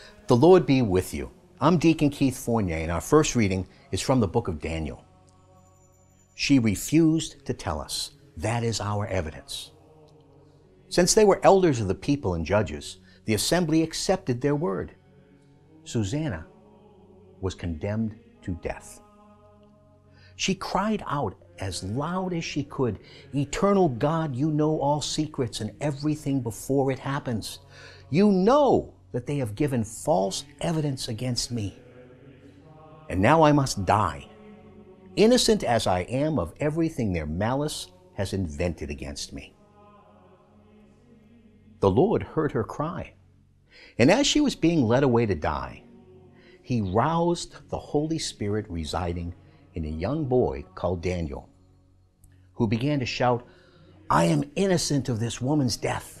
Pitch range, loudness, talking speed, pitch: 95-150 Hz, -25 LUFS, 140 wpm, 120 Hz